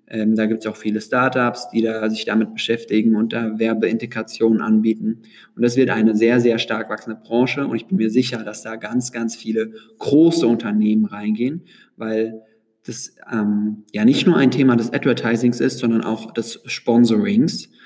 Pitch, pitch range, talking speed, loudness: 115 Hz, 110-120 Hz, 180 wpm, -19 LUFS